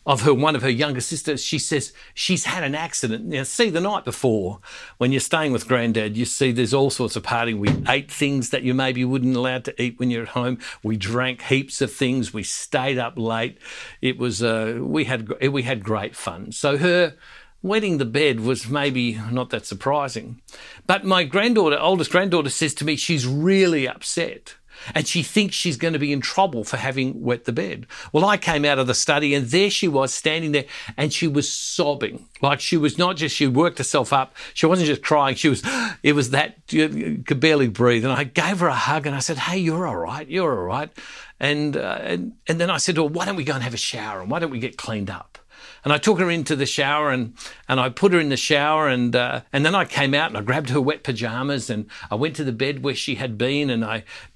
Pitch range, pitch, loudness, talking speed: 125-155 Hz, 140 Hz, -21 LUFS, 245 wpm